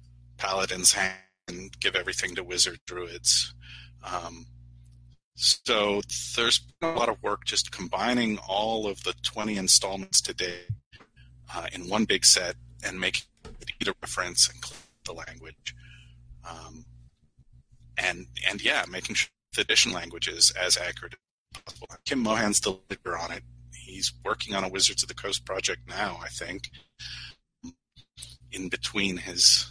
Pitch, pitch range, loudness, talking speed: 85 Hz, 60-100 Hz, -25 LUFS, 140 wpm